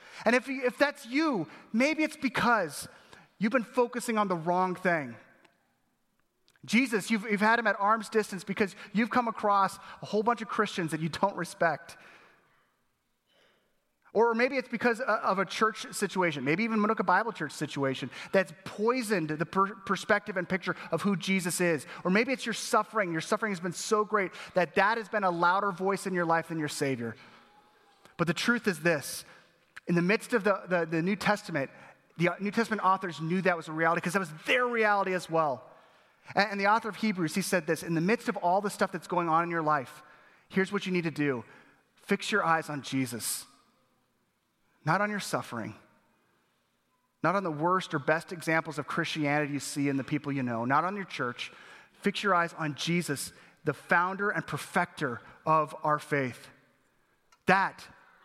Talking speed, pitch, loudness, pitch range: 190 wpm, 185 Hz, -29 LUFS, 160-210 Hz